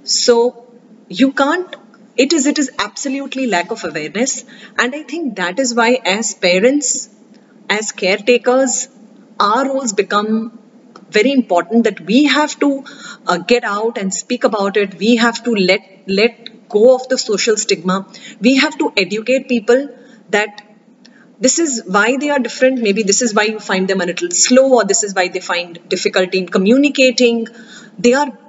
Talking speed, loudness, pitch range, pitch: 170 wpm, -15 LUFS, 205-255 Hz, 230 Hz